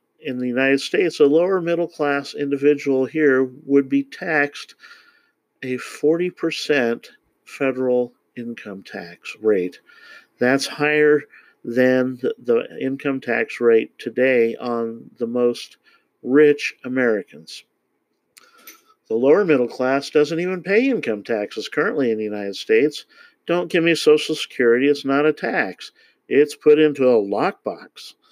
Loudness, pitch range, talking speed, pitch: -19 LUFS, 130-190 Hz, 125 wpm, 145 Hz